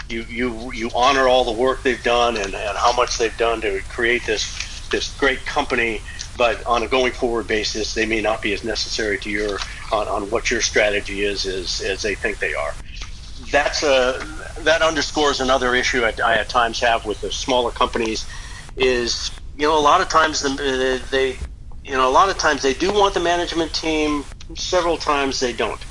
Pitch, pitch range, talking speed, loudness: 130 Hz, 115-150 Hz, 205 wpm, -20 LUFS